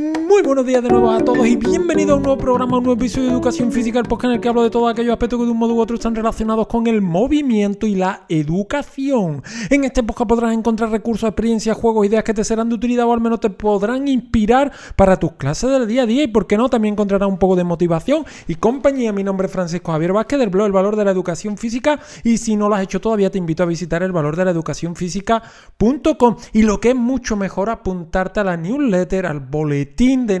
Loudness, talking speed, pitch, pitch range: -17 LUFS, 245 wpm, 225 Hz, 190-245 Hz